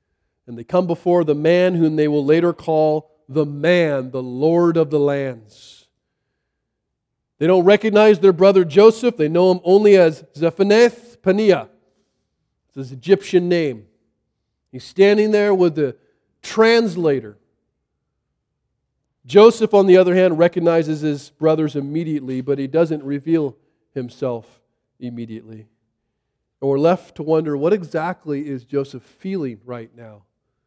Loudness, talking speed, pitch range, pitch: -17 LUFS, 135 wpm, 135-180 Hz, 155 Hz